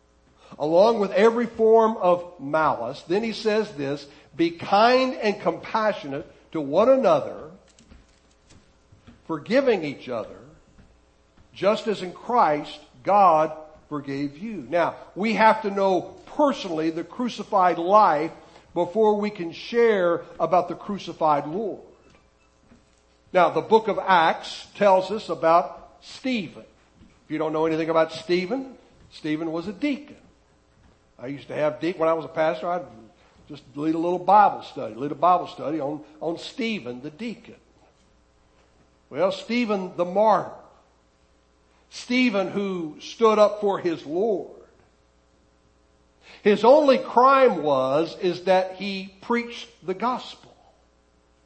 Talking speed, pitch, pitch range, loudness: 130 wpm, 170 Hz, 145-210 Hz, -23 LUFS